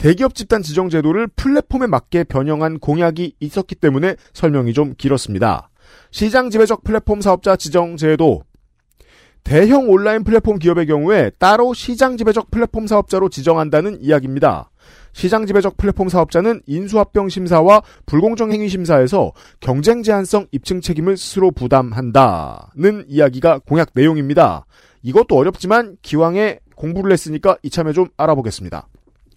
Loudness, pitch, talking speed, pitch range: -15 LUFS, 180 Hz, 360 characters per minute, 155-210 Hz